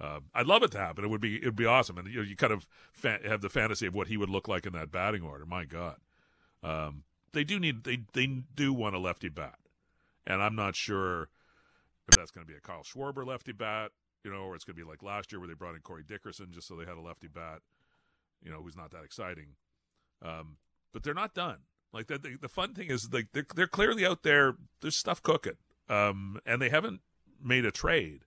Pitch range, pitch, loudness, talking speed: 85-130 Hz, 100 Hz, -29 LUFS, 250 wpm